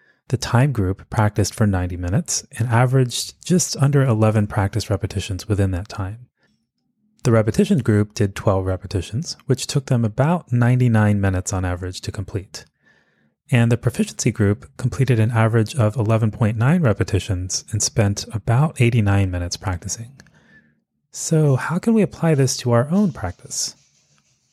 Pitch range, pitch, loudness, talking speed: 100-130 Hz, 115 Hz, -20 LUFS, 145 wpm